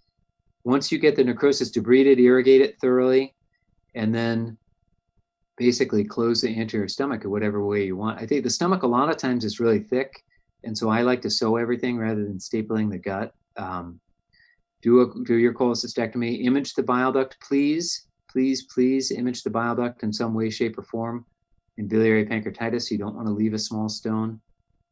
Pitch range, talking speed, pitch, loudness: 105-125 Hz, 190 wpm, 115 Hz, -23 LUFS